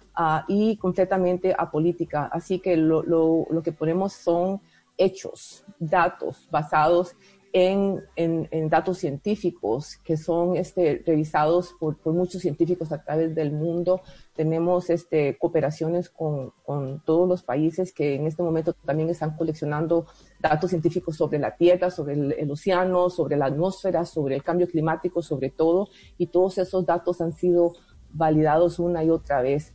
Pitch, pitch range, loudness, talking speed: 170 Hz, 155-180 Hz, -24 LUFS, 155 wpm